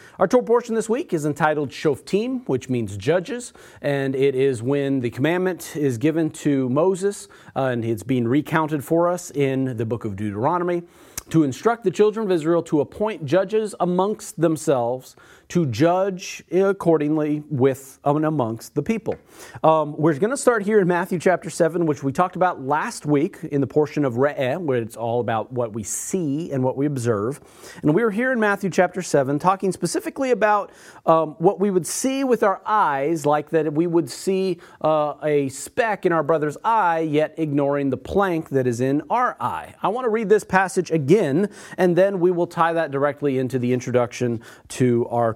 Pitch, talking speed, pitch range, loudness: 160 Hz, 190 wpm, 140-185 Hz, -21 LUFS